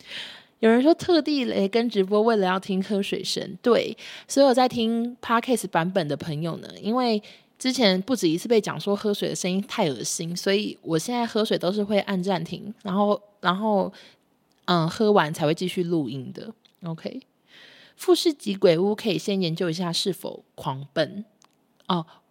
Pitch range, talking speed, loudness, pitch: 180-230 Hz, 265 characters per minute, -24 LUFS, 200 Hz